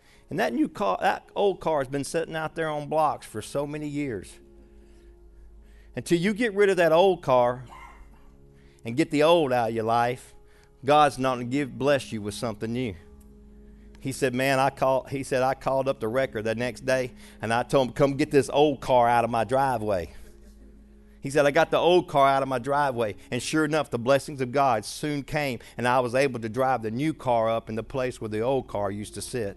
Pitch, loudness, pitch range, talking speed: 130 Hz, -25 LUFS, 110-145 Hz, 225 wpm